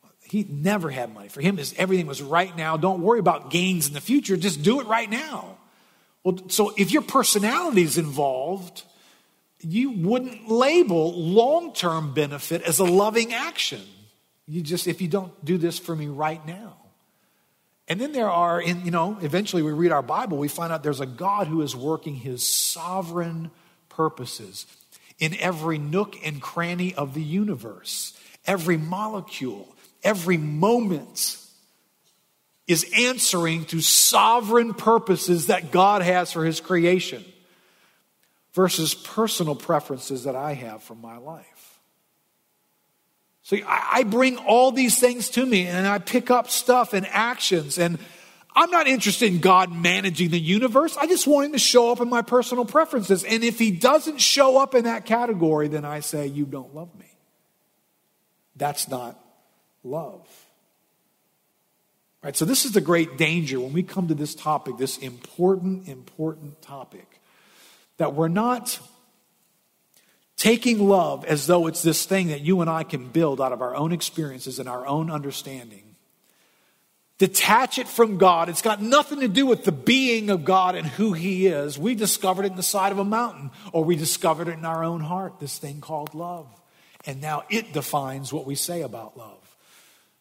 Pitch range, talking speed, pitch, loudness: 155-215 Hz, 165 wpm, 180 Hz, -22 LUFS